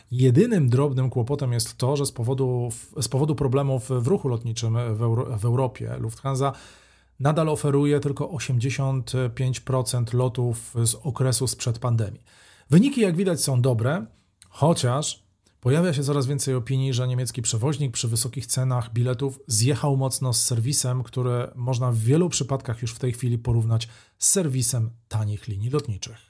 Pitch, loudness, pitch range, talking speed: 130 Hz, -23 LUFS, 120-140 Hz, 150 wpm